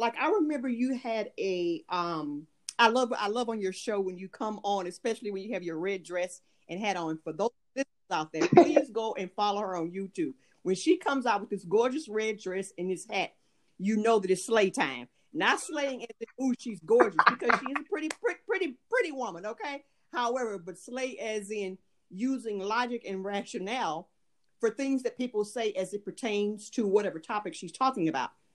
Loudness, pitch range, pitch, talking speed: -30 LUFS, 195-260 Hz, 220 Hz, 200 wpm